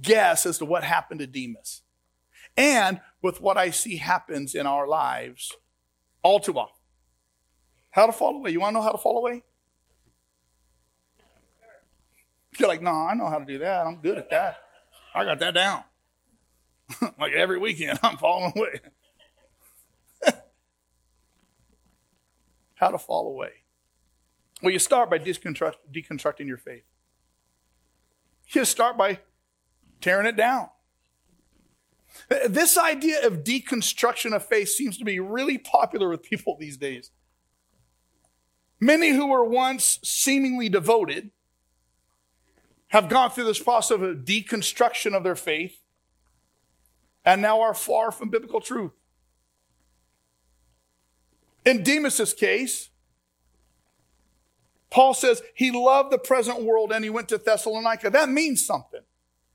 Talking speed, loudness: 130 wpm, -23 LUFS